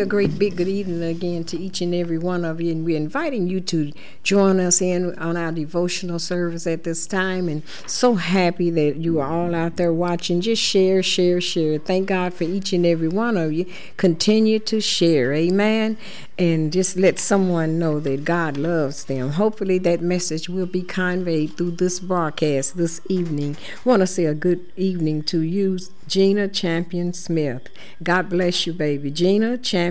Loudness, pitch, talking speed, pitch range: -21 LUFS, 175 Hz, 185 wpm, 165-185 Hz